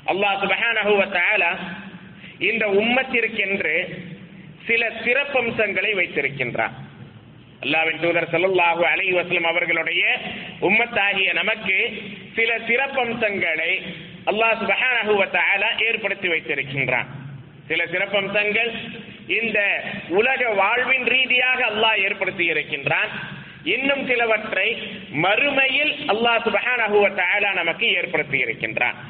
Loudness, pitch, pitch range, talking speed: -19 LUFS, 200 Hz, 170-225 Hz, 80 wpm